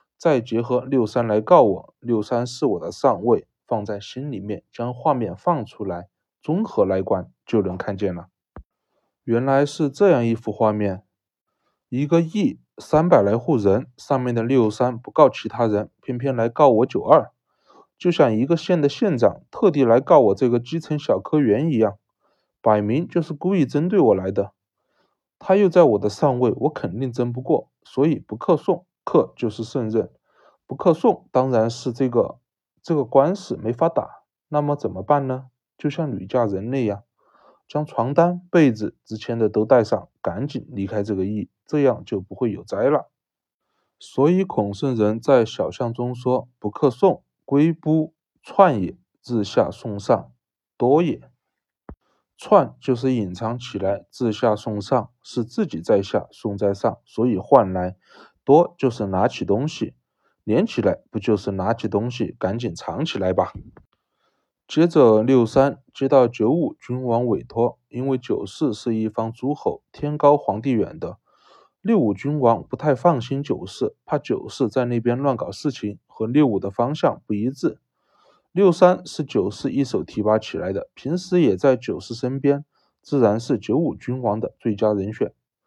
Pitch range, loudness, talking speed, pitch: 110-145 Hz, -21 LUFS, 235 characters per minute, 125 Hz